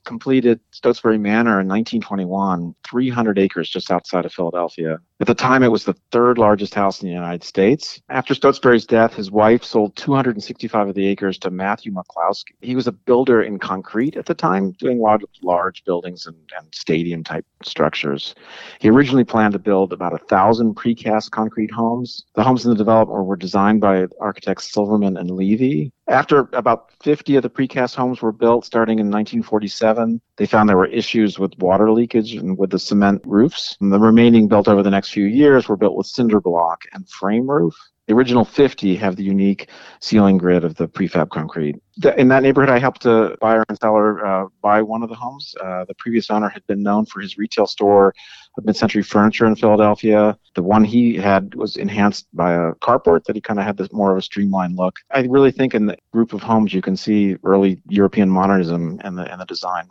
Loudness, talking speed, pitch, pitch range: -17 LUFS, 200 wpm, 105 Hz, 95-115 Hz